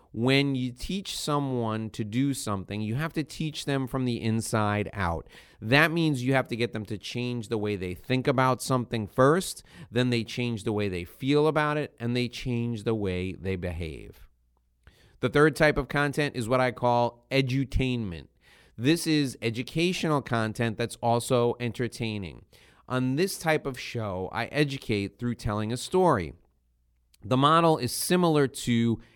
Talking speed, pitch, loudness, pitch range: 165 wpm, 120 Hz, -27 LUFS, 110-140 Hz